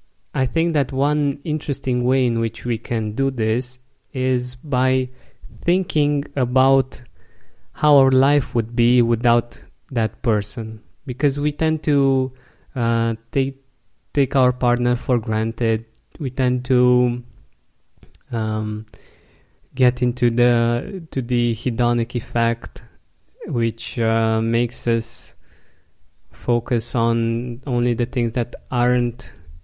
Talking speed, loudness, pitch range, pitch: 115 wpm, -20 LUFS, 115-130 Hz, 120 Hz